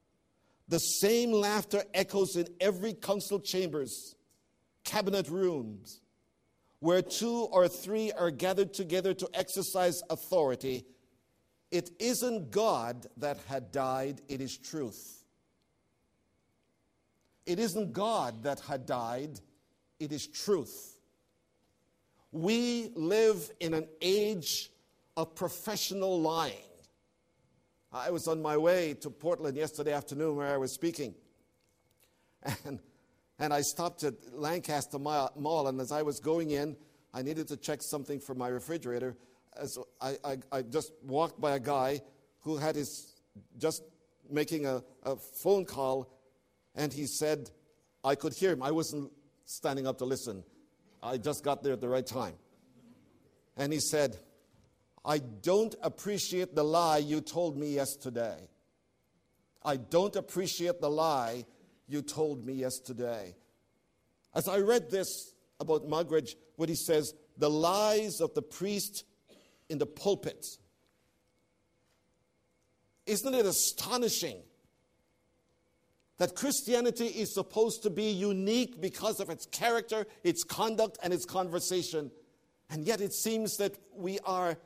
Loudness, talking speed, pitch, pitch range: -33 LUFS, 130 wpm, 160 Hz, 140-190 Hz